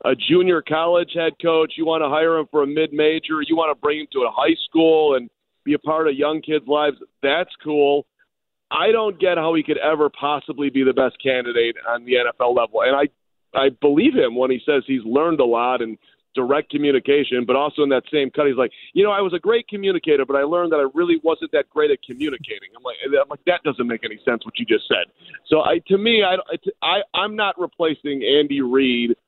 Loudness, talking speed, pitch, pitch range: -19 LUFS, 235 wpm, 155 Hz, 140-175 Hz